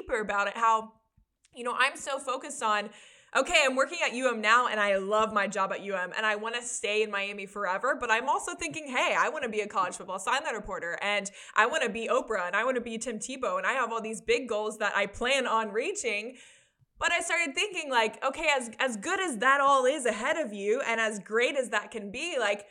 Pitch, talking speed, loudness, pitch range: 230 Hz, 250 wpm, -28 LUFS, 210-270 Hz